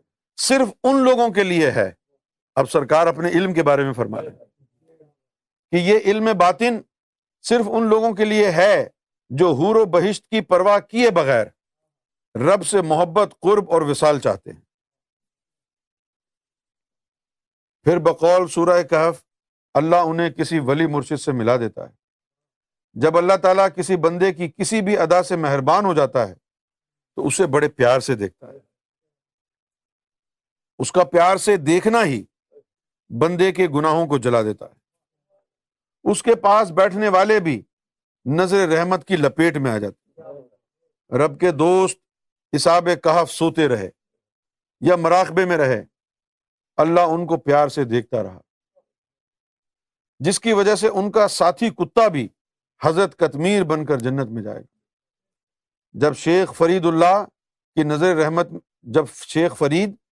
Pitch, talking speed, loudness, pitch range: 175 Hz, 145 wpm, -18 LUFS, 150-195 Hz